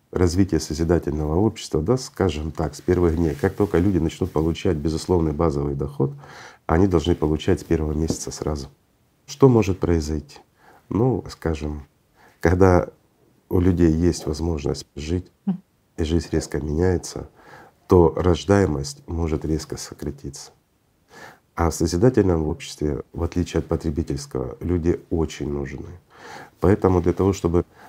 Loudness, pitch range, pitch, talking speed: -22 LUFS, 75-90 Hz, 85 Hz, 125 wpm